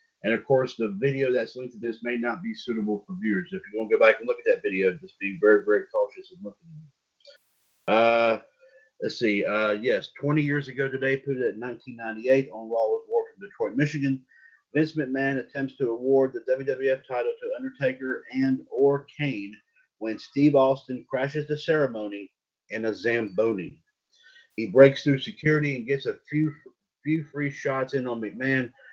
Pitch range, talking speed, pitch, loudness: 125-175 Hz, 190 wpm, 135 Hz, -26 LUFS